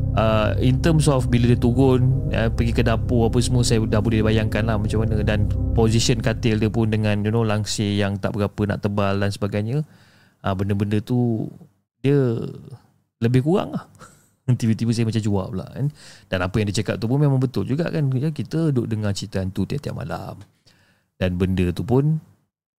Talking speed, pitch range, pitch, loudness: 185 wpm, 105-125 Hz, 110 Hz, -21 LUFS